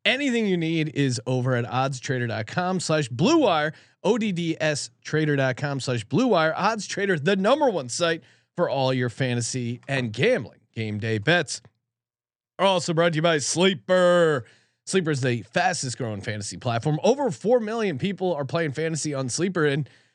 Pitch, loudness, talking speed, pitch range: 150 Hz, -24 LUFS, 160 wpm, 125-180 Hz